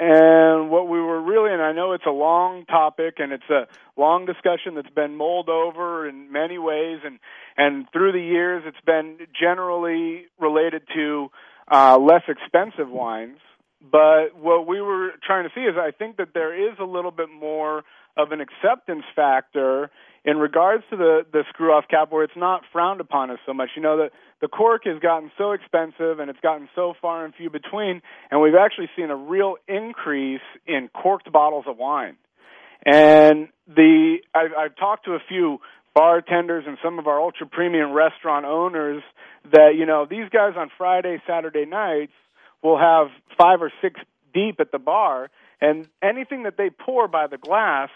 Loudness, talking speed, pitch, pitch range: -20 LUFS, 180 wpm, 165 Hz, 150-180 Hz